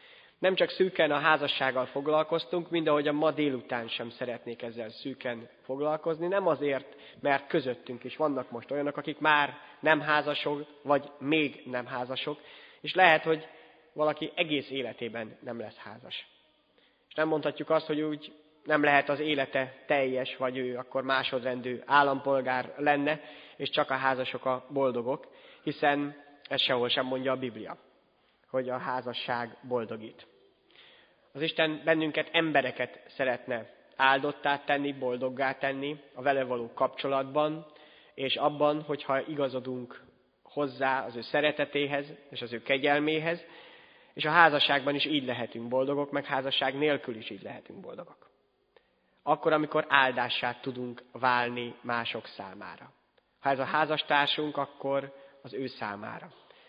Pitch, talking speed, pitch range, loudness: 140 Hz, 135 wpm, 130-150 Hz, -29 LUFS